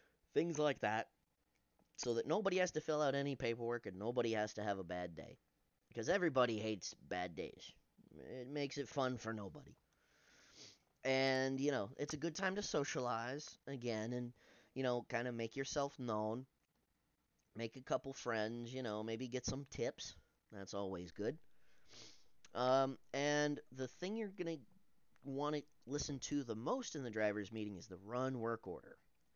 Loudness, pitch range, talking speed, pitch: -42 LUFS, 110-145 Hz, 170 wpm, 125 Hz